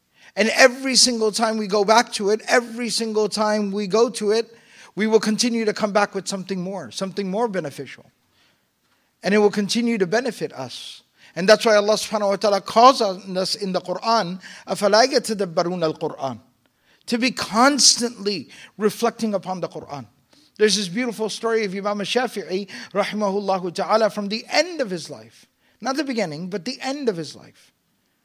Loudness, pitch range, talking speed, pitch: -20 LUFS, 190-230 Hz, 170 wpm, 210 Hz